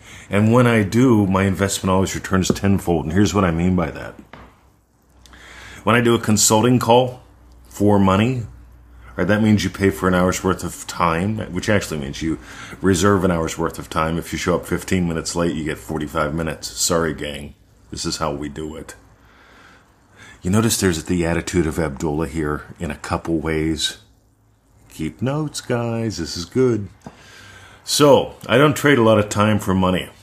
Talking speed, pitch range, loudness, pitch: 185 wpm, 80-105 Hz, -19 LUFS, 95 Hz